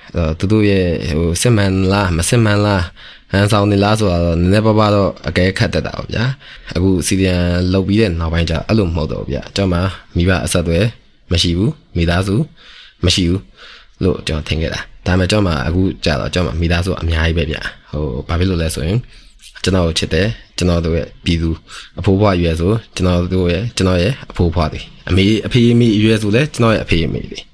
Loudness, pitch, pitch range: -16 LUFS, 90 Hz, 85-105 Hz